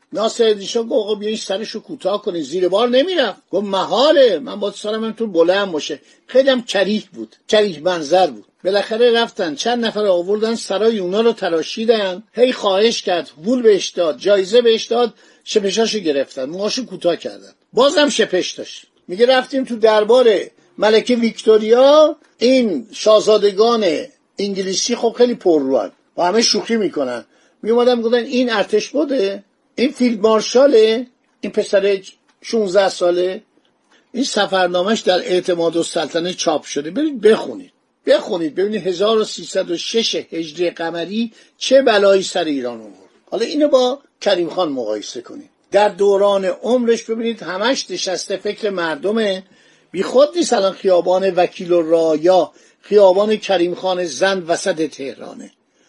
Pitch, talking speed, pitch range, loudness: 210 Hz, 140 wpm, 185-240 Hz, -16 LUFS